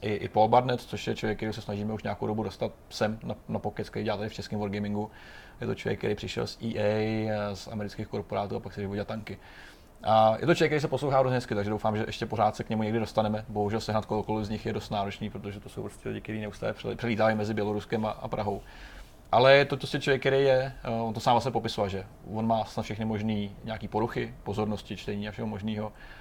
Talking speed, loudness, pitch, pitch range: 230 wpm, -29 LUFS, 110 Hz, 105-115 Hz